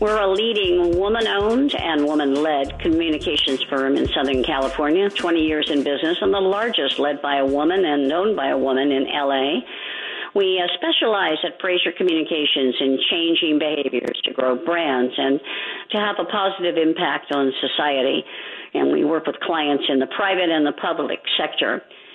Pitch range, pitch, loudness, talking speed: 140-190 Hz, 155 Hz, -20 LUFS, 165 wpm